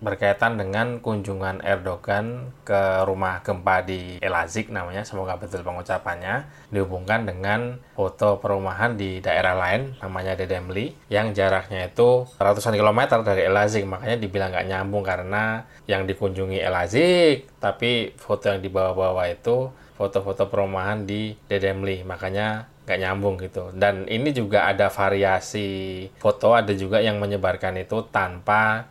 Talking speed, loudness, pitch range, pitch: 130 wpm, -23 LUFS, 95-110 Hz, 100 Hz